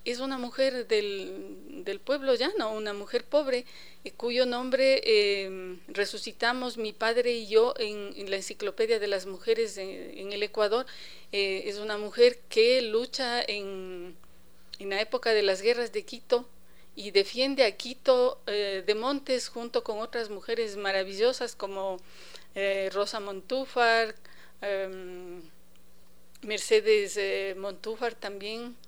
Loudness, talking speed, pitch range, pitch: -28 LUFS, 135 wpm, 200-250 Hz, 220 Hz